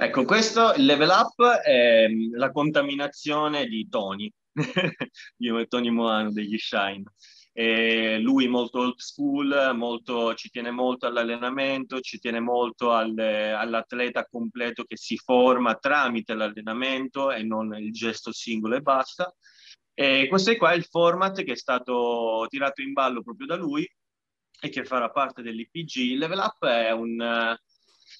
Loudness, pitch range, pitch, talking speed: -24 LUFS, 115-140 Hz, 120 Hz, 150 wpm